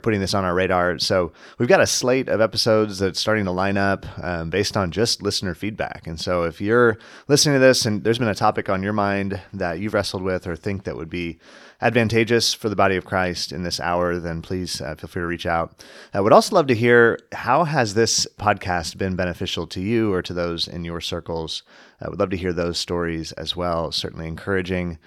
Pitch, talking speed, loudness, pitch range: 95 Hz, 225 wpm, -21 LUFS, 85-110 Hz